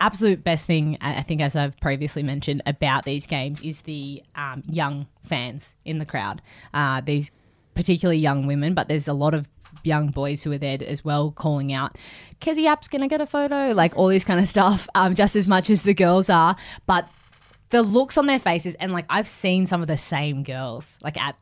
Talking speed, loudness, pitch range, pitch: 215 wpm, -22 LUFS, 140-185 Hz, 155 Hz